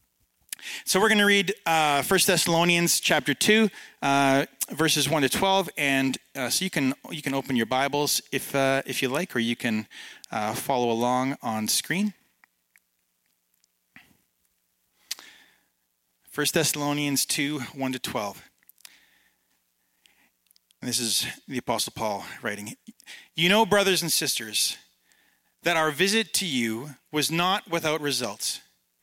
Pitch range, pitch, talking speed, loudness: 115-170 Hz, 140 Hz, 135 wpm, -24 LUFS